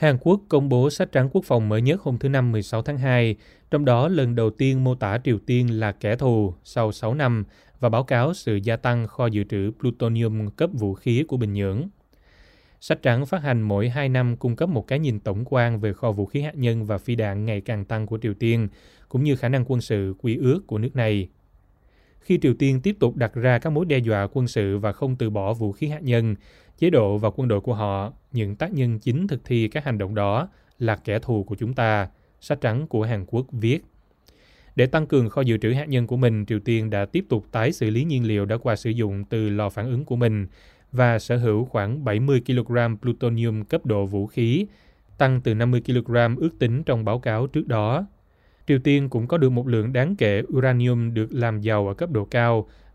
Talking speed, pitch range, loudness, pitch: 235 wpm, 110-130 Hz, -23 LUFS, 120 Hz